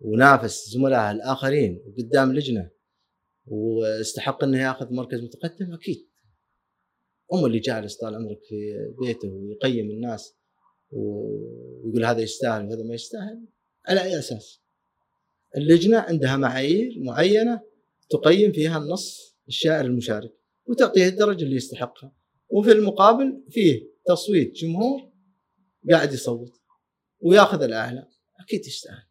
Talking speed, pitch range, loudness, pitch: 110 wpm, 115-190 Hz, -22 LUFS, 135 Hz